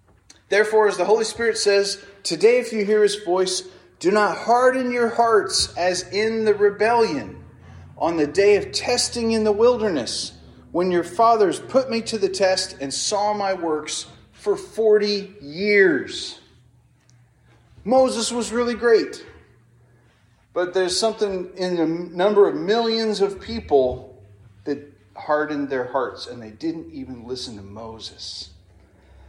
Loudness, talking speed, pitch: -21 LUFS, 140 wpm, 195 Hz